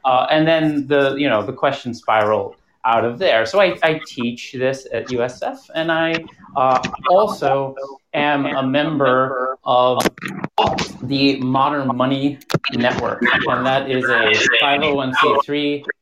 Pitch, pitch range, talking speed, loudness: 135 Hz, 130-145 Hz, 155 wpm, -18 LUFS